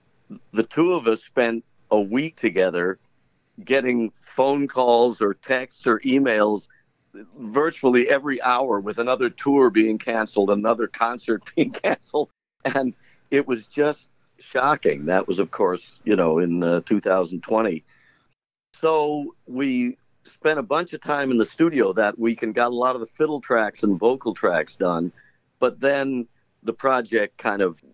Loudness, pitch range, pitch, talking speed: -22 LUFS, 110-140 Hz, 125 Hz, 150 wpm